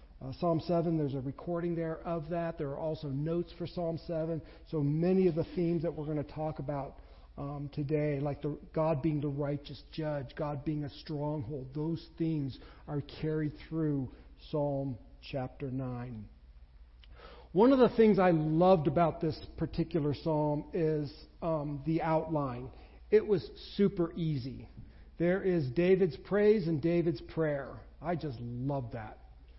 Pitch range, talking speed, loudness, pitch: 140-170 Hz, 155 wpm, -33 LUFS, 155 Hz